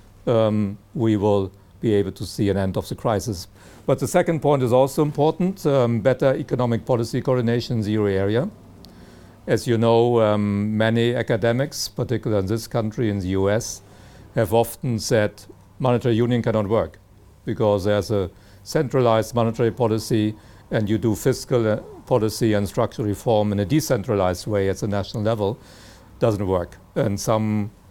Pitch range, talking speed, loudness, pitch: 100-120 Hz, 160 wpm, -22 LUFS, 110 Hz